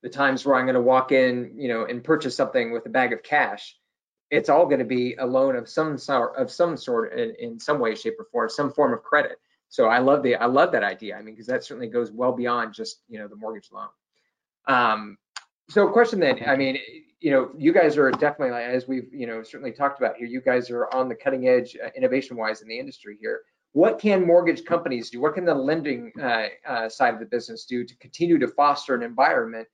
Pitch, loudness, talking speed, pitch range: 130 Hz, -23 LUFS, 240 wpm, 120-170 Hz